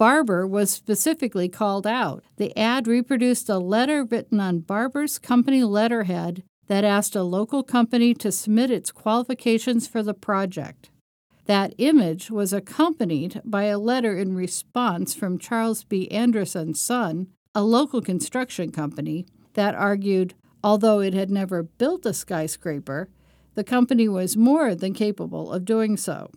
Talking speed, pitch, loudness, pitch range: 145 wpm, 210 Hz, -23 LUFS, 185-235 Hz